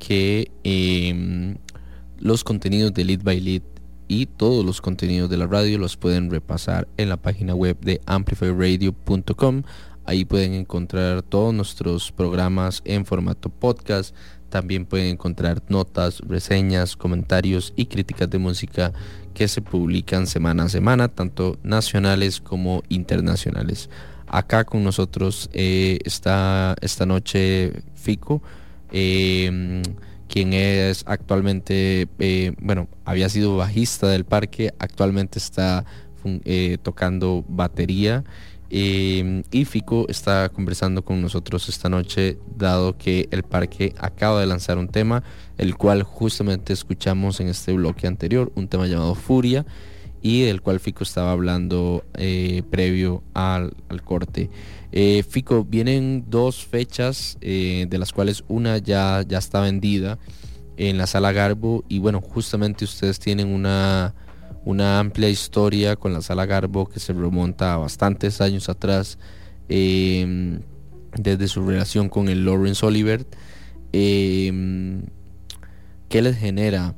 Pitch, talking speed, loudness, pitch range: 95 Hz, 130 wpm, -22 LUFS, 90-100 Hz